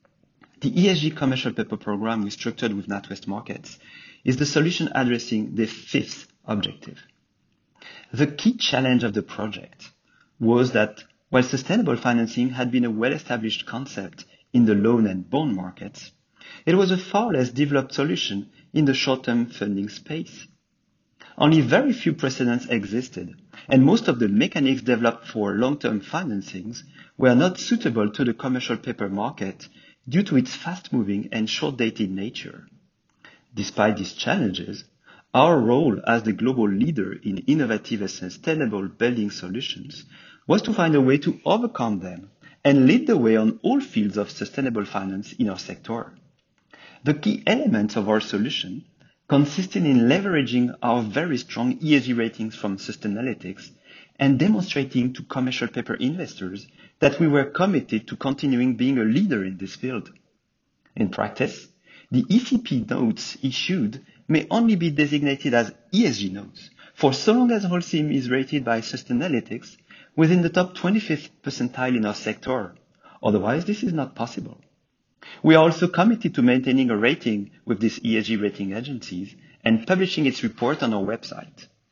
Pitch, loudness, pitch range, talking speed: 125 Hz, -23 LUFS, 110-155 Hz, 150 wpm